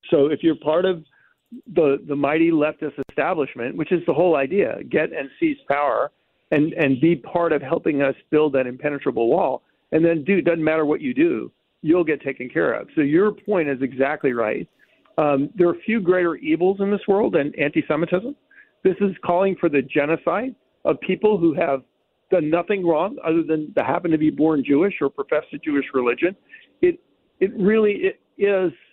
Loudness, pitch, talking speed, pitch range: -21 LUFS, 165 Hz, 190 wpm, 150-200 Hz